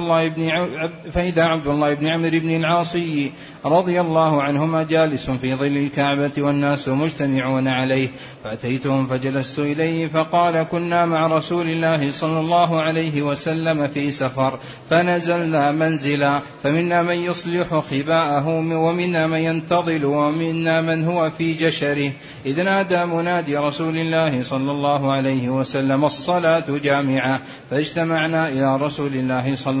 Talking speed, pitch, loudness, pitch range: 130 wpm, 155 Hz, -20 LUFS, 140-165 Hz